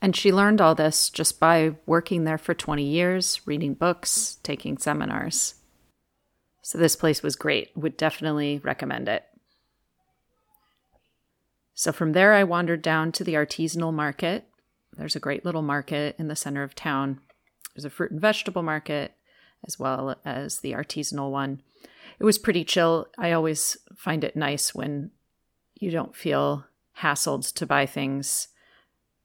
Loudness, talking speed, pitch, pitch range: -25 LUFS, 150 wpm, 160 Hz, 145-175 Hz